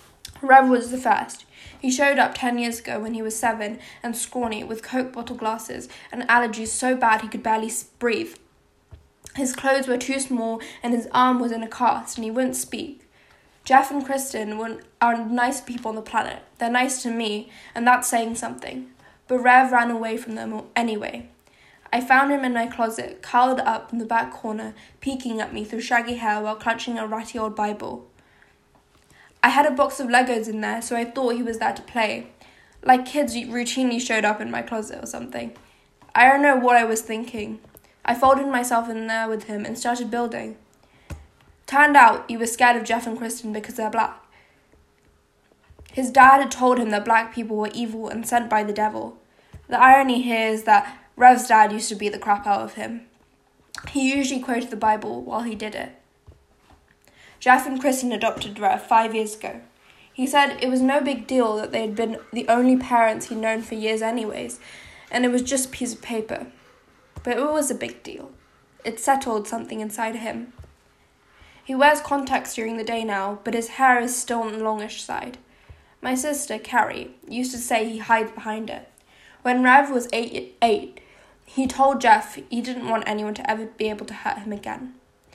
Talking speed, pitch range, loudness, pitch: 195 wpm, 220-255 Hz, -22 LUFS, 235 Hz